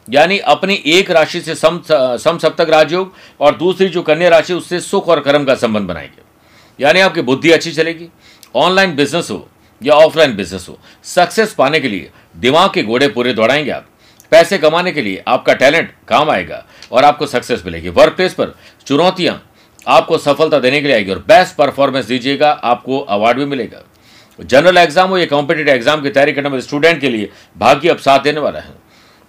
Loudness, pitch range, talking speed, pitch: -12 LUFS, 140-175 Hz, 190 wpm, 155 Hz